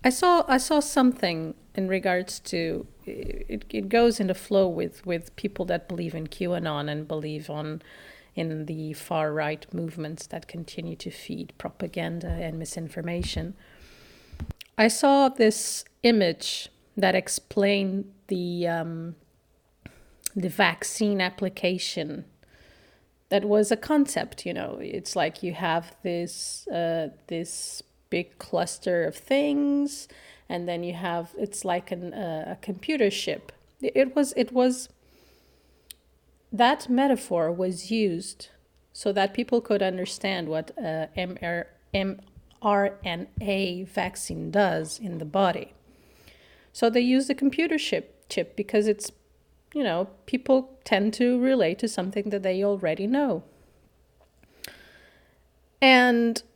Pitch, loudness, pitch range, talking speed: 190 Hz, -26 LUFS, 165-225 Hz, 125 wpm